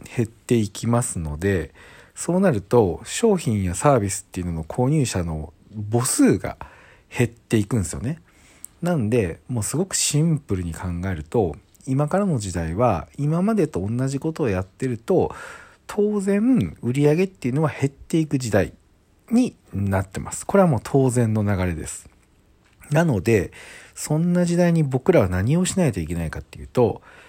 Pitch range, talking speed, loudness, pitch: 95-155 Hz, 320 characters per minute, -22 LUFS, 120 Hz